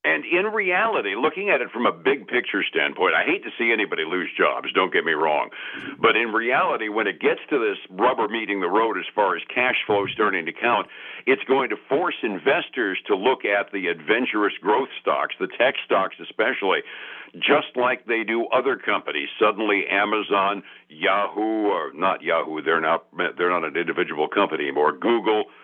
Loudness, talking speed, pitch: -22 LUFS, 180 wpm, 120 Hz